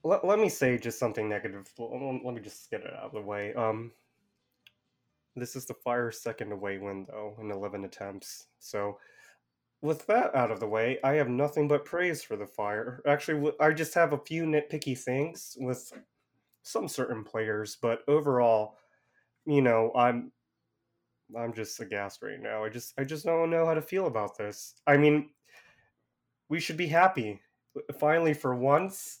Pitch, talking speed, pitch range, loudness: 125 Hz, 175 wpm, 110-150 Hz, -30 LUFS